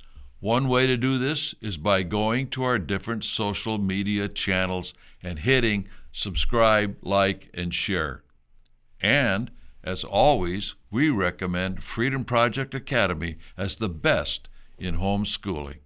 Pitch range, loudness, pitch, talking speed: 90-115 Hz, -25 LUFS, 100 Hz, 125 wpm